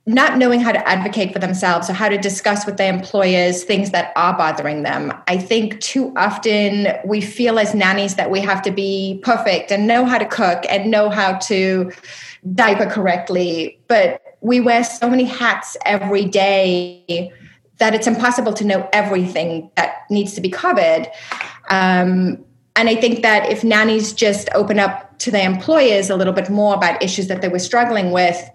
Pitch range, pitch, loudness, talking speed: 185-225 Hz, 200 Hz, -16 LUFS, 185 wpm